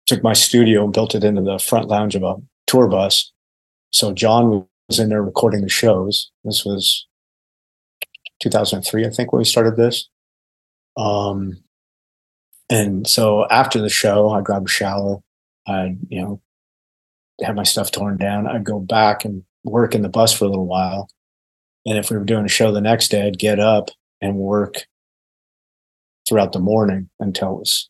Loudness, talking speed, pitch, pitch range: -17 LUFS, 175 wpm, 105 Hz, 95-110 Hz